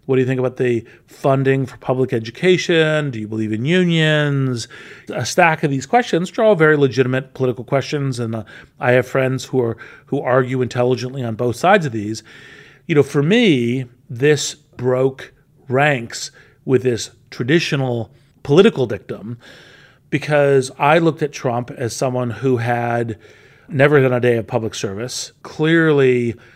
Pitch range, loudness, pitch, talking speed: 120-145 Hz, -17 LUFS, 130 Hz, 155 wpm